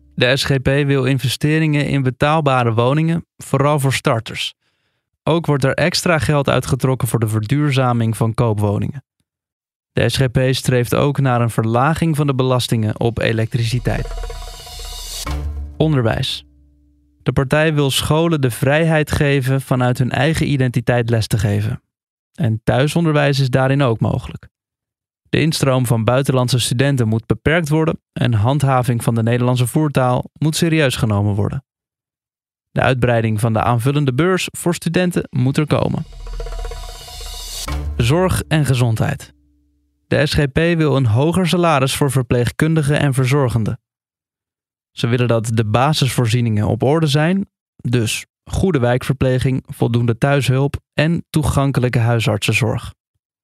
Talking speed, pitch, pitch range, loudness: 125 wpm, 130 Hz, 115-145 Hz, -17 LUFS